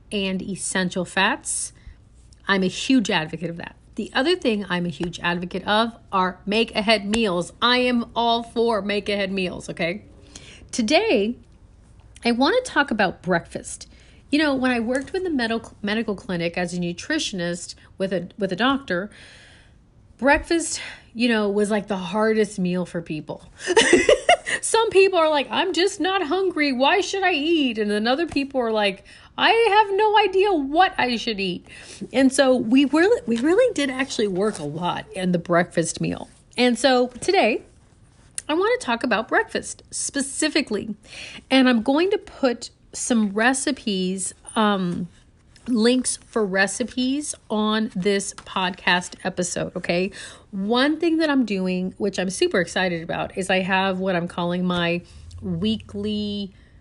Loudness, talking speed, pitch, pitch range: -22 LUFS, 155 wpm, 220 Hz, 185-280 Hz